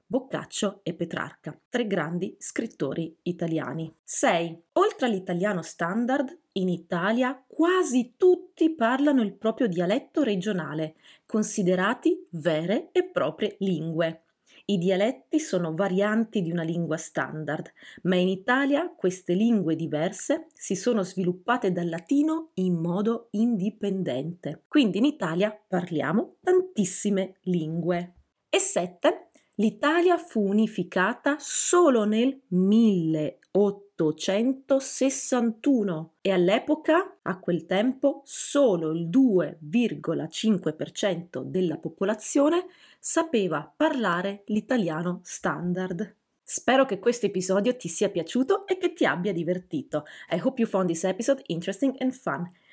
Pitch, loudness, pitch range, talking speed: 205 Hz, -26 LUFS, 175-260 Hz, 110 wpm